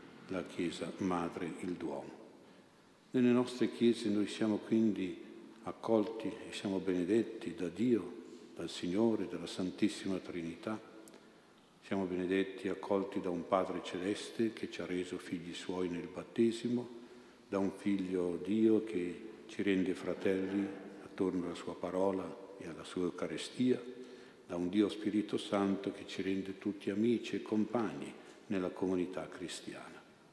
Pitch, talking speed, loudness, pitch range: 100 Hz, 135 wpm, -37 LUFS, 95-110 Hz